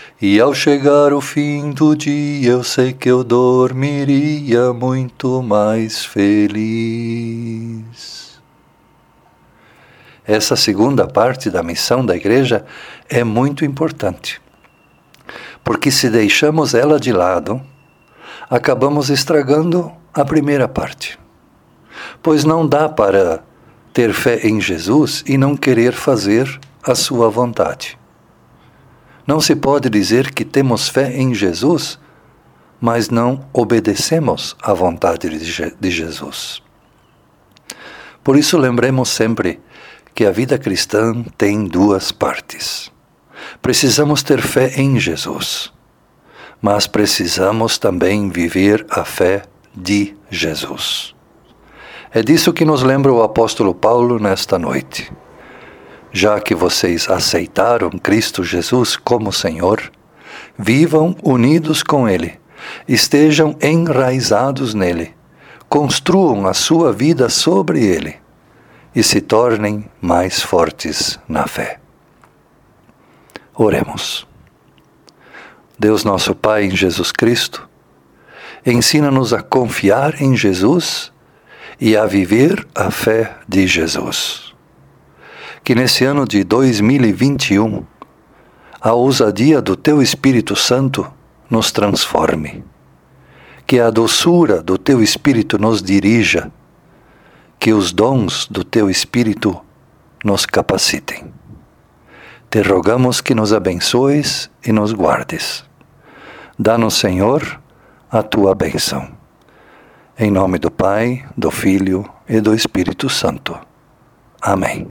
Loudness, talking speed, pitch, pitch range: -14 LUFS, 105 wpm, 120 Hz, 105-140 Hz